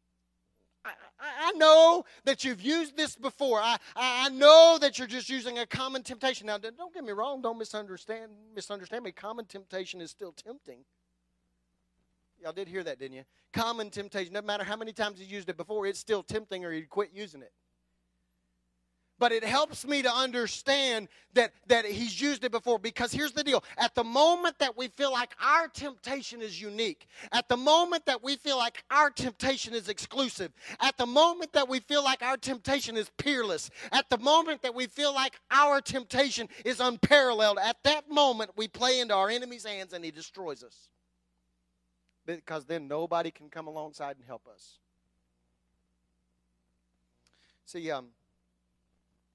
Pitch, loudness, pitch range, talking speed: 225 Hz, -27 LUFS, 155-265 Hz, 175 wpm